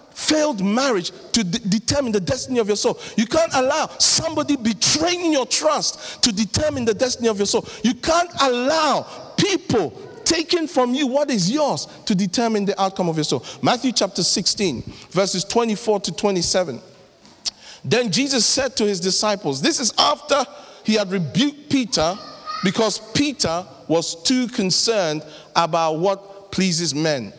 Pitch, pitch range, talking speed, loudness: 225 Hz, 190-275 Hz, 155 wpm, -20 LUFS